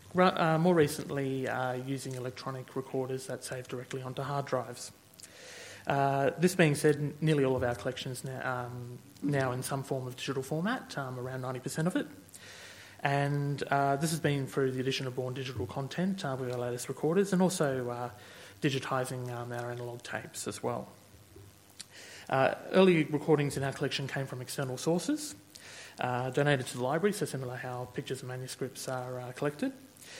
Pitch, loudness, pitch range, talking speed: 135 Hz, -32 LUFS, 125-145 Hz, 180 wpm